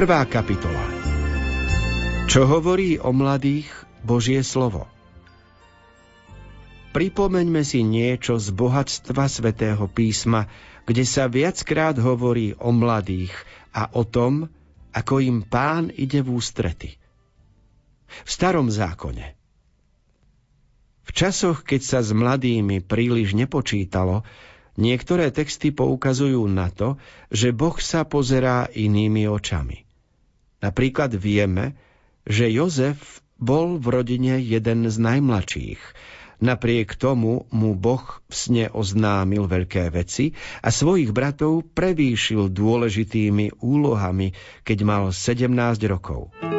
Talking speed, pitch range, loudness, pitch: 105 wpm, 105-135 Hz, -21 LUFS, 115 Hz